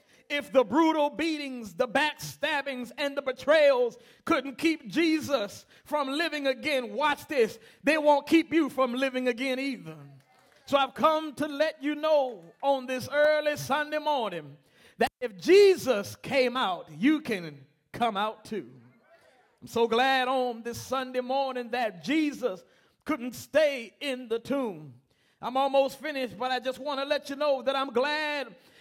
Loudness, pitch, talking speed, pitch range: -27 LUFS, 270 Hz, 155 wpm, 245-295 Hz